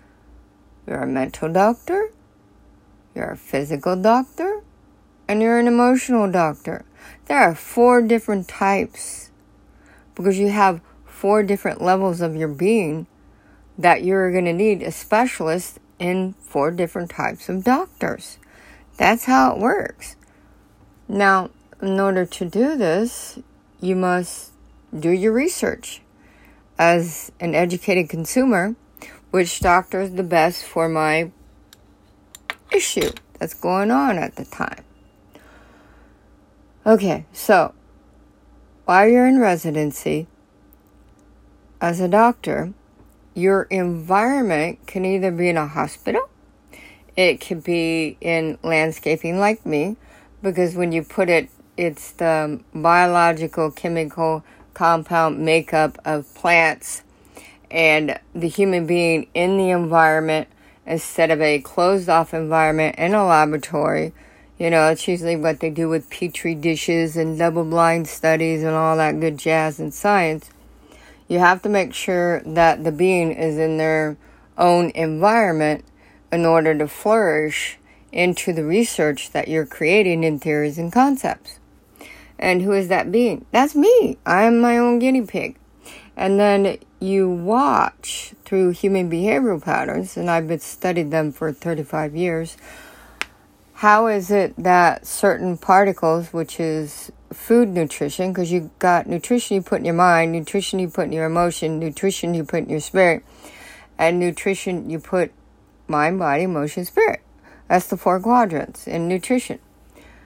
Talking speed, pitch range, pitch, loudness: 135 wpm, 160-195 Hz, 170 Hz, -19 LUFS